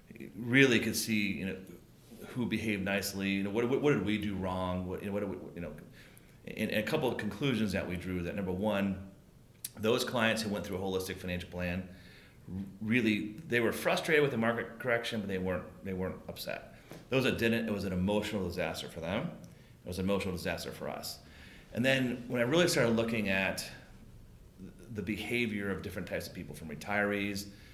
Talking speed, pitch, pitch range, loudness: 195 wpm, 100 Hz, 95-115 Hz, -33 LUFS